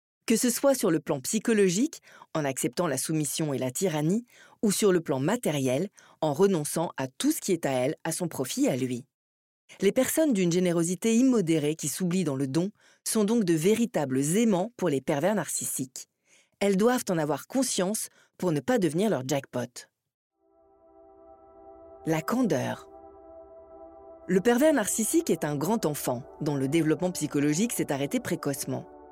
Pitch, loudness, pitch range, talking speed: 165 Hz, -27 LUFS, 135-205 Hz, 165 wpm